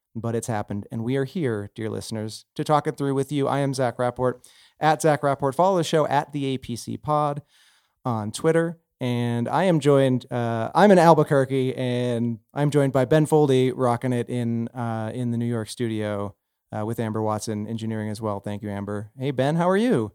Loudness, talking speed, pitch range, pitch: -23 LUFS, 205 wpm, 115-145 Hz, 125 Hz